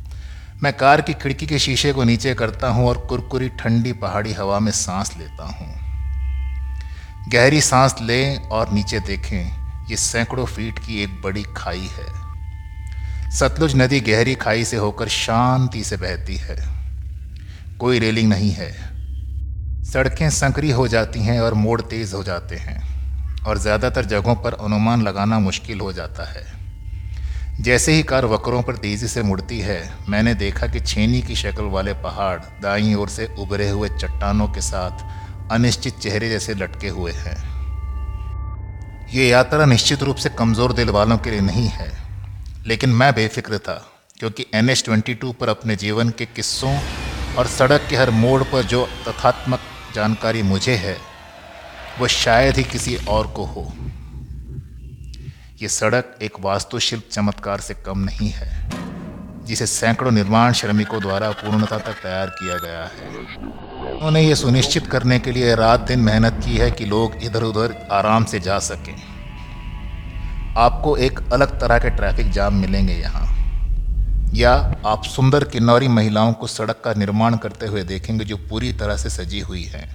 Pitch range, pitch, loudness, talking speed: 90-120 Hz, 105 Hz, -19 LUFS, 160 wpm